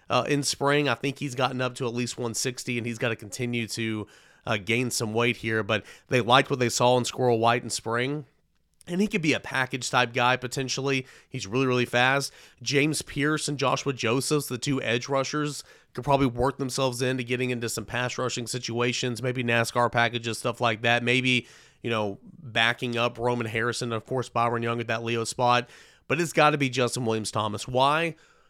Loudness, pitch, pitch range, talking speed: -26 LUFS, 125 Hz, 115-135 Hz, 205 wpm